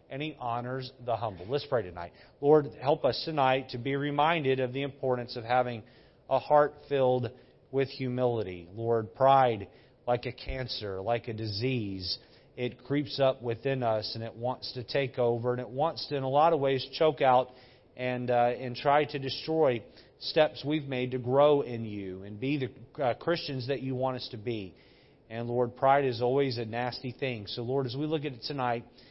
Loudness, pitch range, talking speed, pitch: -30 LUFS, 120-140 Hz, 195 wpm, 125 Hz